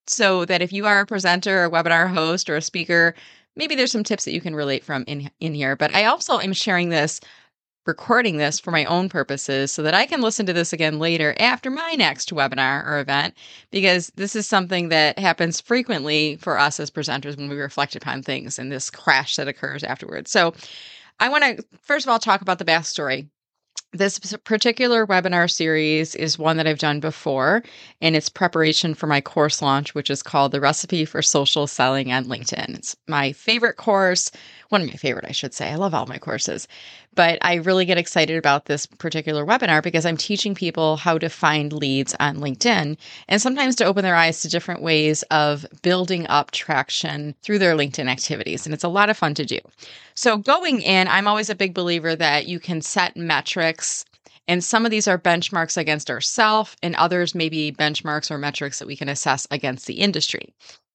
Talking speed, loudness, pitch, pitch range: 205 wpm, -20 LUFS, 165 Hz, 150-190 Hz